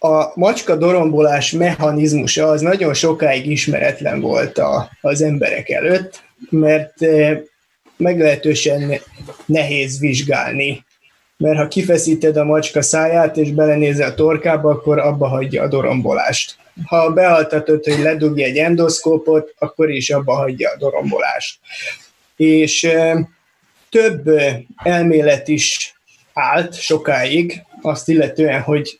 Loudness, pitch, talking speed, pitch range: -15 LUFS, 155 Hz, 110 wpm, 150-165 Hz